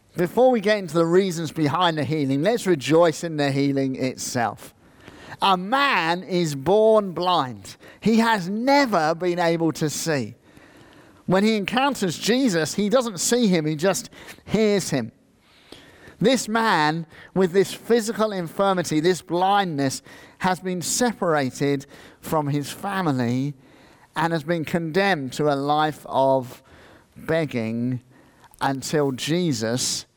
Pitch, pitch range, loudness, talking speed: 165 Hz, 140-195 Hz, -22 LUFS, 125 wpm